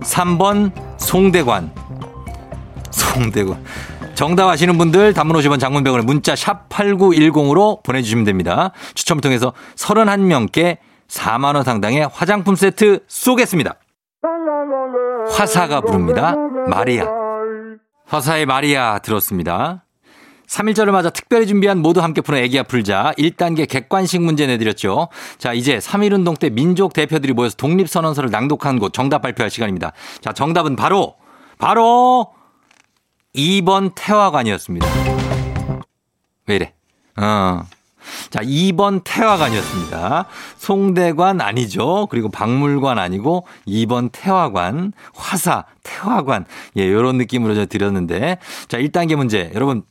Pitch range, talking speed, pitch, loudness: 125-195 Hz, 265 characters per minute, 160 Hz, -16 LUFS